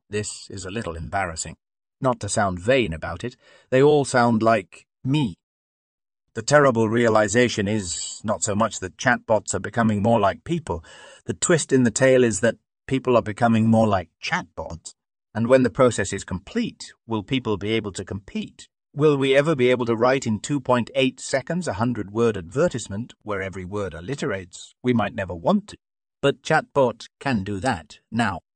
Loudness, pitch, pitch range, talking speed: -22 LUFS, 115 Hz, 100-130 Hz, 175 wpm